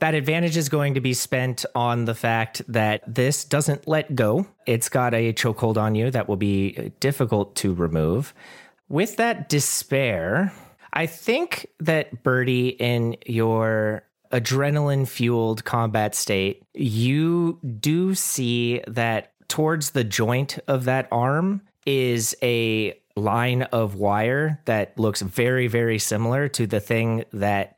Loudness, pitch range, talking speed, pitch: -23 LUFS, 115-145 Hz, 140 wpm, 125 Hz